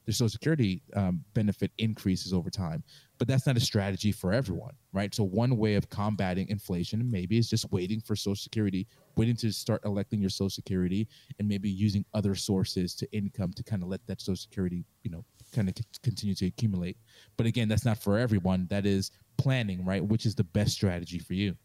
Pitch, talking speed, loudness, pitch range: 105 Hz, 210 wpm, -30 LUFS, 95-115 Hz